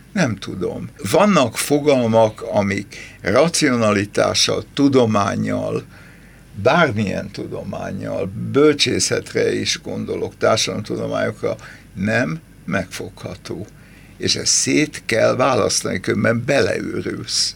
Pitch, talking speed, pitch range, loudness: 115 Hz, 75 wpm, 105-140 Hz, -18 LUFS